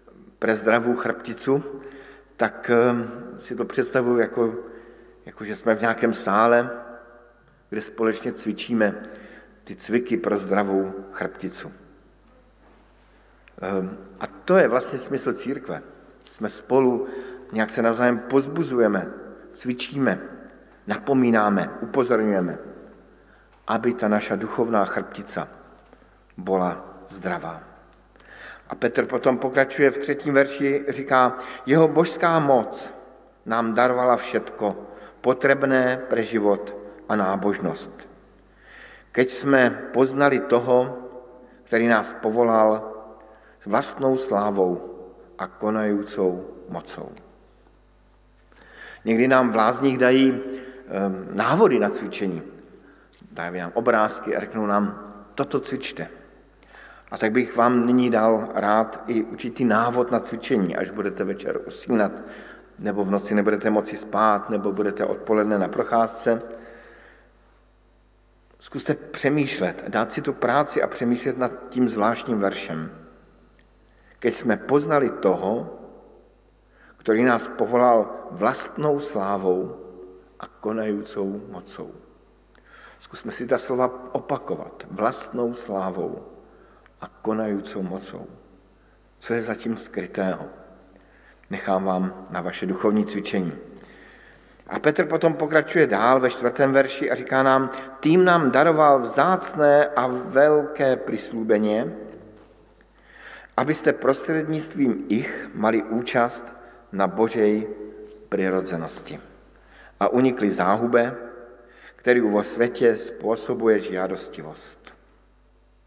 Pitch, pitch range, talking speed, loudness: 115 Hz, 105-125 Hz, 100 wpm, -22 LUFS